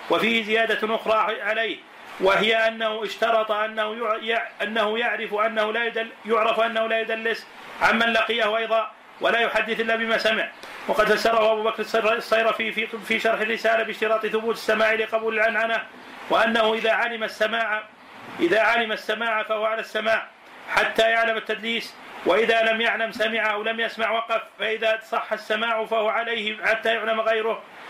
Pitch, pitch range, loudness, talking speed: 220 Hz, 215-225 Hz, -22 LUFS, 140 wpm